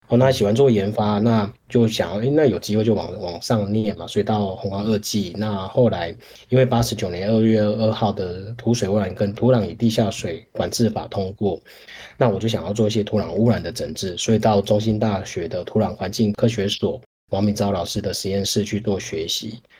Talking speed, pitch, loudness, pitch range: 310 characters per minute, 105 Hz, -21 LUFS, 100-110 Hz